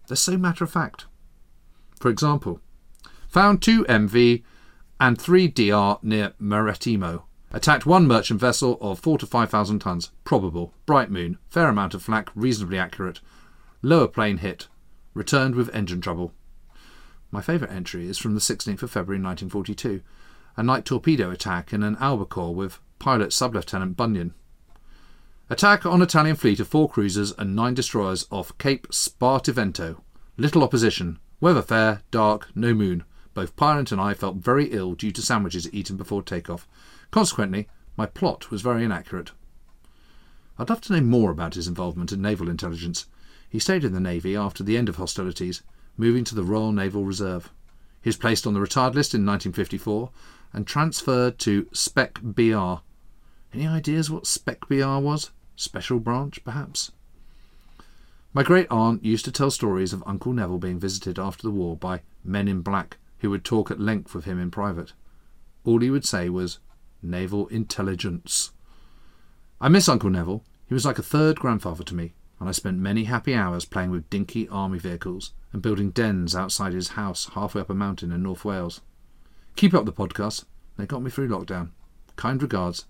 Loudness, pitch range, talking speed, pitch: -24 LUFS, 90-125 Hz, 170 wpm, 105 Hz